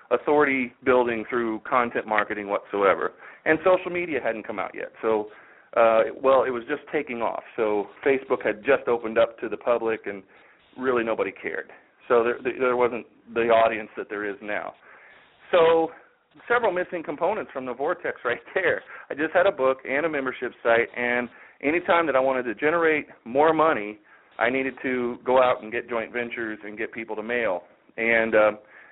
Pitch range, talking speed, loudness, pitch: 110-135 Hz, 180 wpm, -24 LUFS, 120 Hz